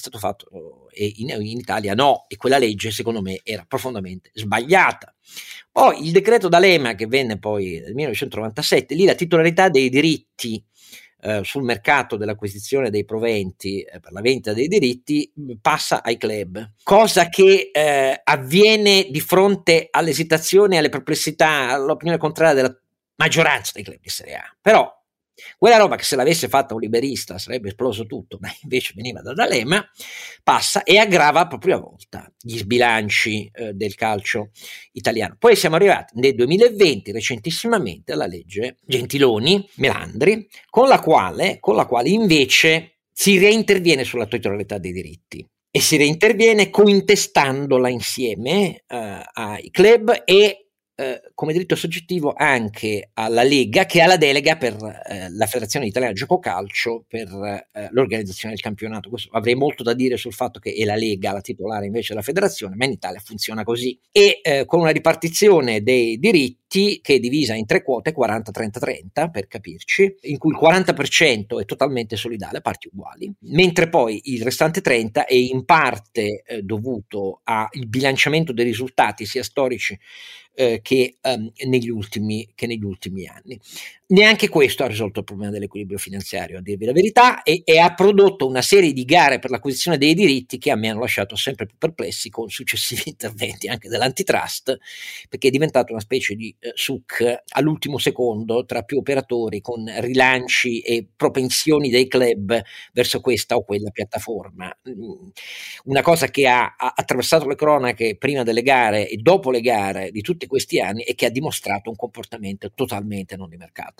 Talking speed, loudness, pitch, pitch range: 160 wpm, -18 LUFS, 125 Hz, 110-160 Hz